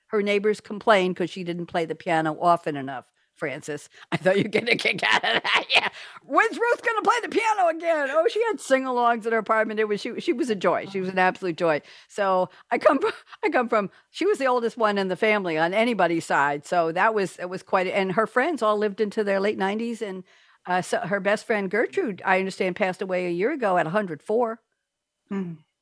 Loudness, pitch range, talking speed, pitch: -24 LUFS, 180-235 Hz, 230 wpm, 205 Hz